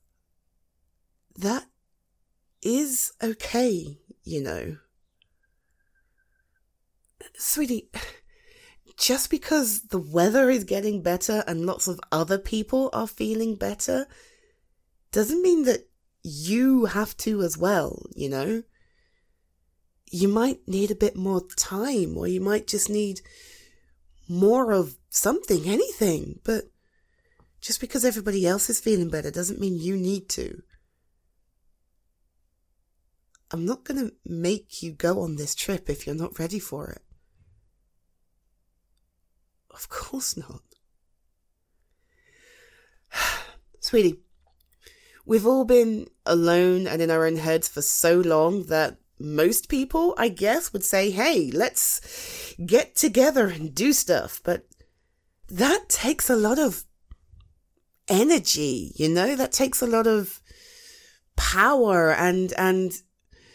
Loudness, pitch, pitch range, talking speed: -24 LUFS, 195 Hz, 155-255 Hz, 115 wpm